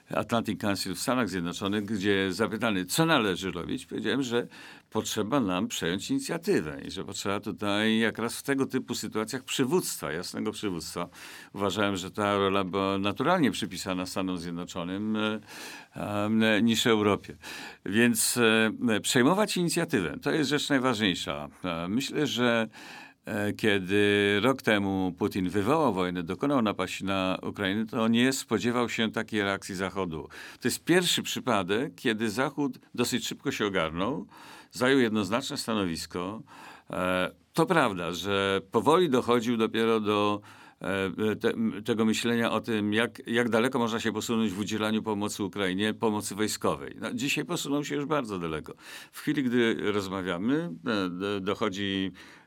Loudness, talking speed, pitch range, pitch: -28 LUFS, 130 wpm, 100-120 Hz, 110 Hz